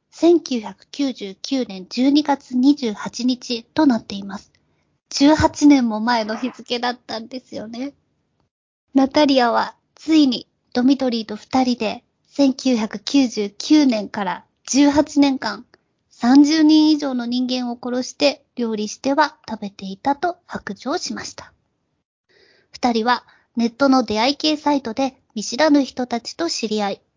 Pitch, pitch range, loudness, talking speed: 255 Hz, 230-285 Hz, -19 LUFS, 220 characters per minute